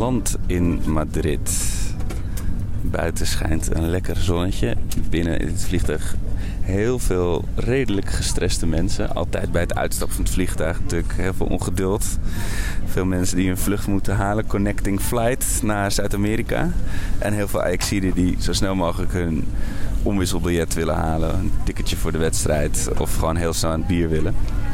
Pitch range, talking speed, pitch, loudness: 85-100 Hz, 155 wpm, 95 Hz, -23 LUFS